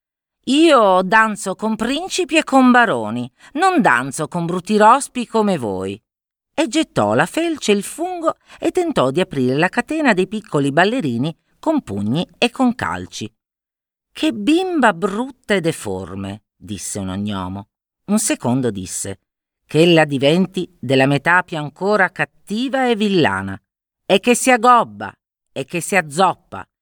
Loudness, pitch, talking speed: -17 LUFS, 185 Hz, 145 wpm